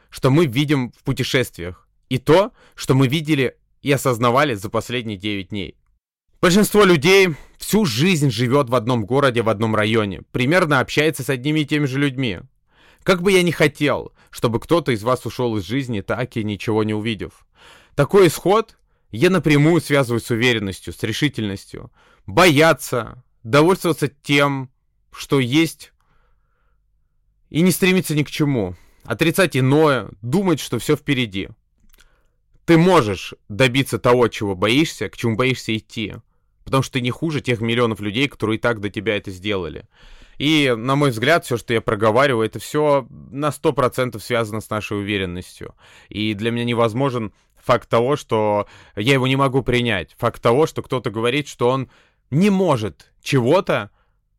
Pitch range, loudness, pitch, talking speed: 110-145 Hz, -19 LUFS, 125 Hz, 155 wpm